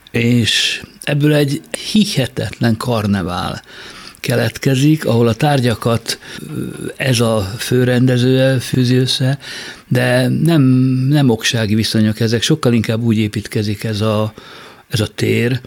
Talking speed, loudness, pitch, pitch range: 110 wpm, -15 LUFS, 120 Hz, 110-130 Hz